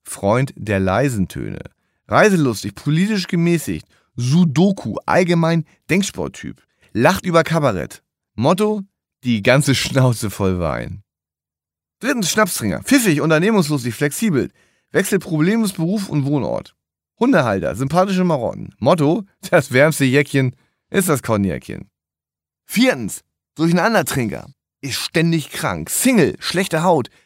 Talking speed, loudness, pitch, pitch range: 105 wpm, -18 LUFS, 155 Hz, 115-185 Hz